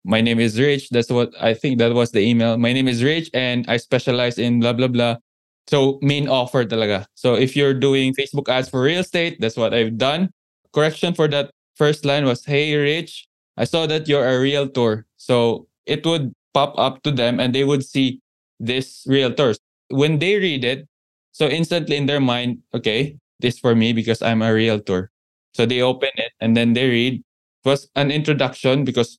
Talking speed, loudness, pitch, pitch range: 200 wpm, -19 LUFS, 130 Hz, 120-145 Hz